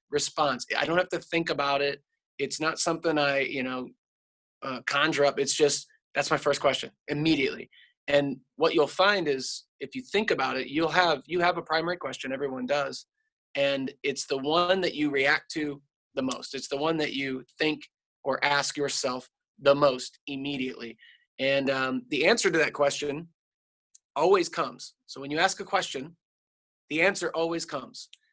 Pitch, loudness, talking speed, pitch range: 145 Hz, -27 LUFS, 180 wpm, 135-170 Hz